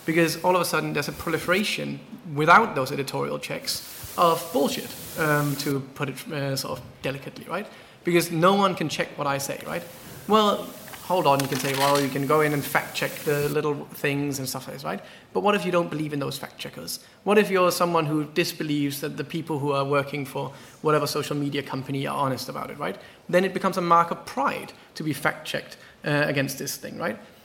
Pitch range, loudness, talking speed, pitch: 140-170 Hz, -25 LUFS, 225 wpm, 150 Hz